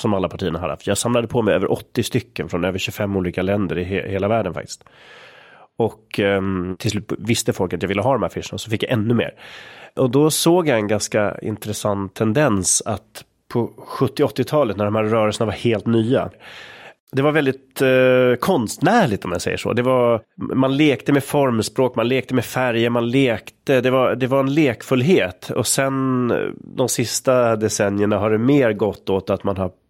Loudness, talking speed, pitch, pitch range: -19 LUFS, 195 wpm, 115 Hz, 100-130 Hz